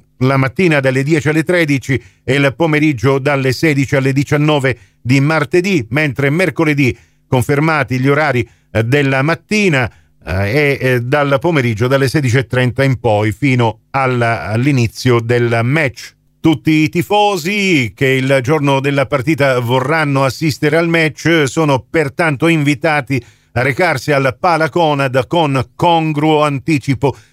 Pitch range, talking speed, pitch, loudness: 130-155 Hz, 120 wpm, 140 Hz, -14 LUFS